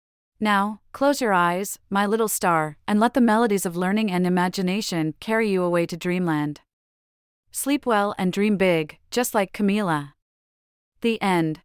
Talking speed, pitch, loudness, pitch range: 155 wpm, 190 Hz, -23 LUFS, 160-215 Hz